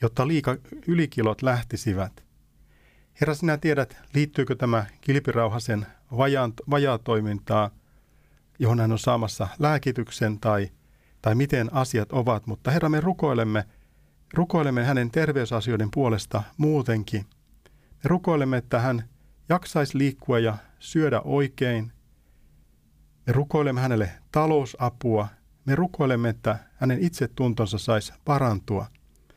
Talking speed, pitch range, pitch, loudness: 105 wpm, 110-140 Hz, 125 Hz, -25 LUFS